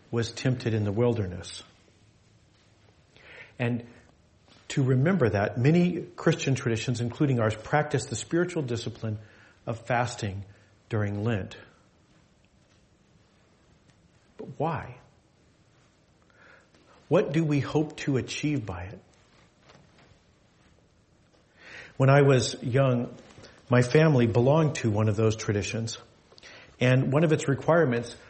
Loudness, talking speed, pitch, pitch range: -26 LUFS, 105 wpm, 120 Hz, 110-135 Hz